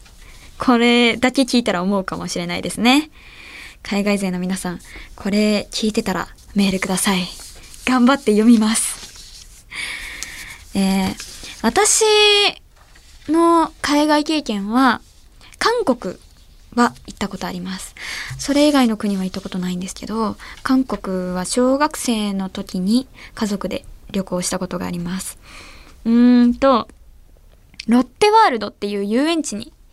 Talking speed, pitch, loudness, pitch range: 260 characters per minute, 215 Hz, -18 LUFS, 190-260 Hz